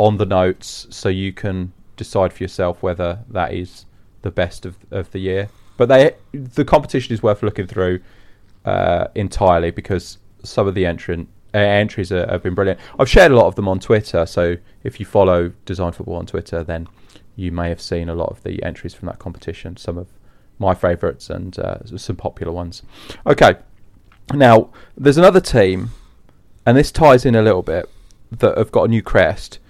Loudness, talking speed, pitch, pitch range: -17 LUFS, 190 wpm, 95 Hz, 90-105 Hz